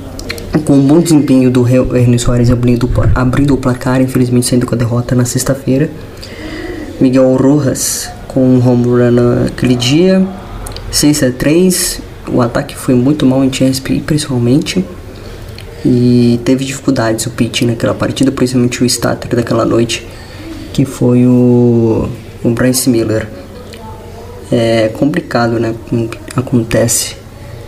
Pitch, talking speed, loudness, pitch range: 125 Hz, 125 wpm, -11 LUFS, 115-130 Hz